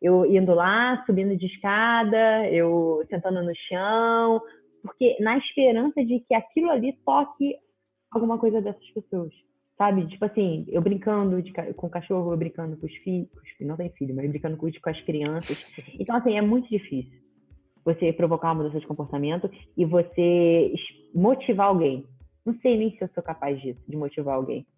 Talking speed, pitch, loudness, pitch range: 180 wpm, 185 Hz, -24 LUFS, 165-225 Hz